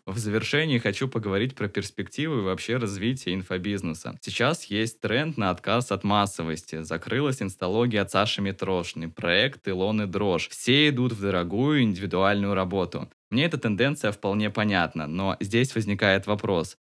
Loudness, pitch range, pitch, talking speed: -26 LUFS, 95-115 Hz, 100 Hz, 145 wpm